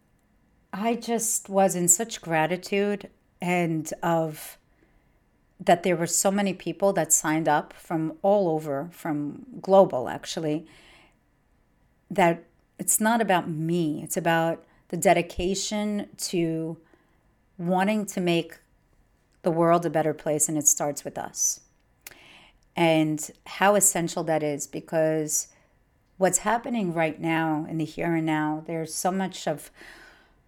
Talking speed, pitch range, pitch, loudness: 130 wpm, 155-190 Hz, 170 Hz, -25 LUFS